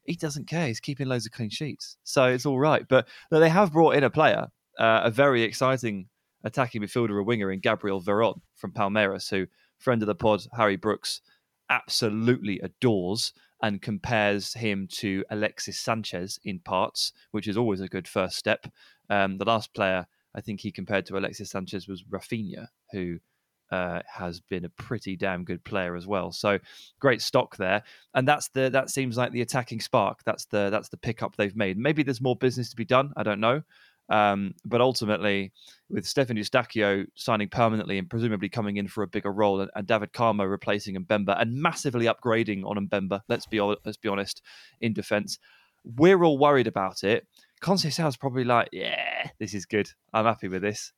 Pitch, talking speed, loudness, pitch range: 110 Hz, 190 wpm, -26 LUFS, 100-125 Hz